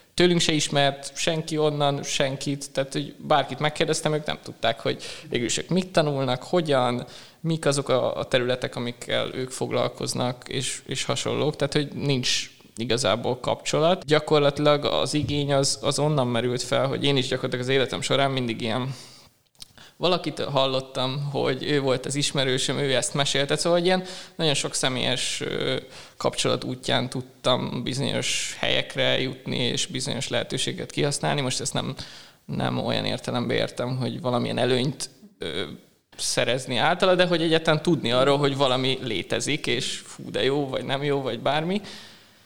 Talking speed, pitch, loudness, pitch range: 145 wpm, 140 Hz, -24 LUFS, 130-155 Hz